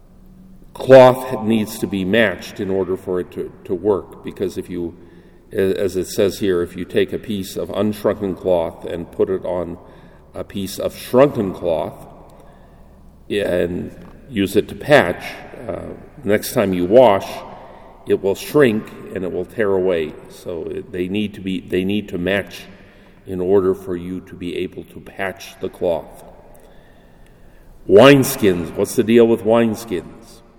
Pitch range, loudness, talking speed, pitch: 90-110 Hz, -18 LUFS, 155 wpm, 95 Hz